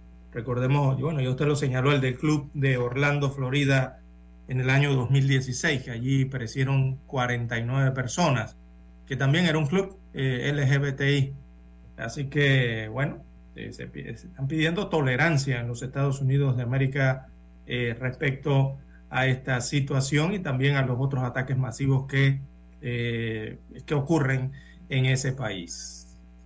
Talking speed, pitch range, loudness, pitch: 145 wpm, 120-140 Hz, -26 LUFS, 130 Hz